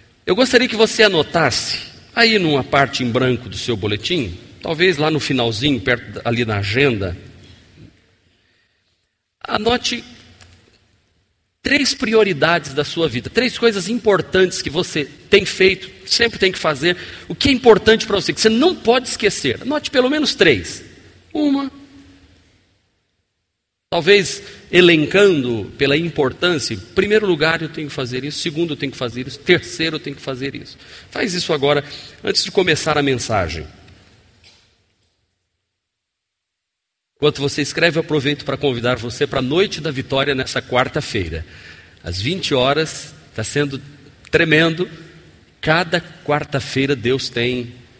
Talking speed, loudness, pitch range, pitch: 140 wpm, -17 LUFS, 115-180 Hz, 145 Hz